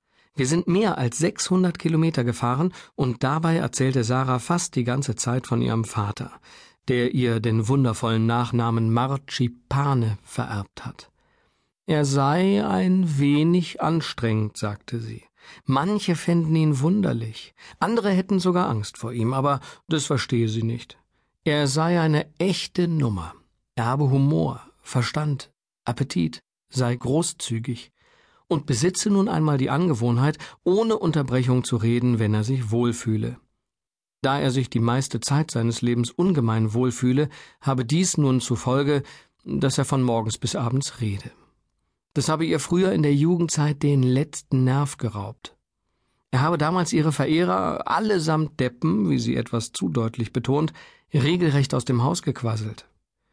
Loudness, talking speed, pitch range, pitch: -23 LUFS, 140 wpm, 120-160 Hz, 135 Hz